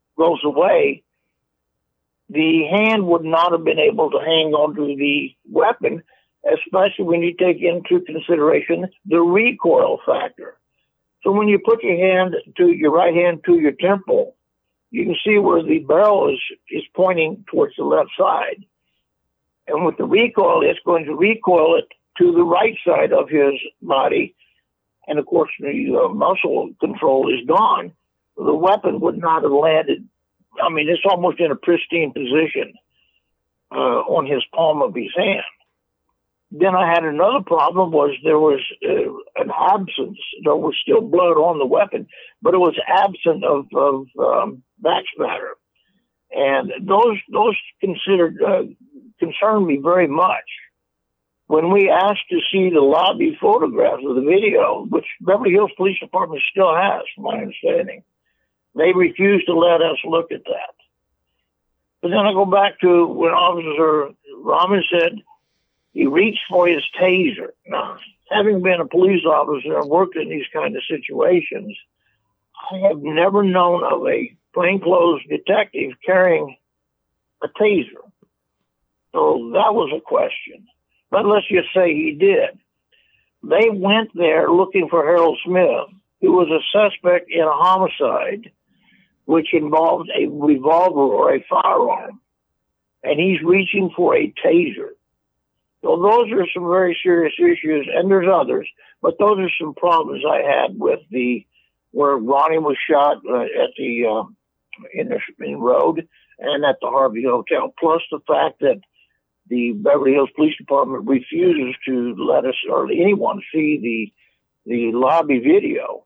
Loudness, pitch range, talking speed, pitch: -17 LUFS, 155-235 Hz, 150 wpm, 180 Hz